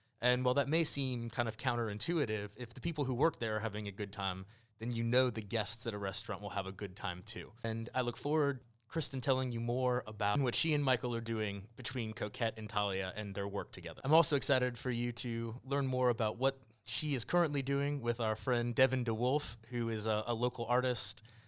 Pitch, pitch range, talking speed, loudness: 120 Hz, 110-130 Hz, 230 wpm, -35 LUFS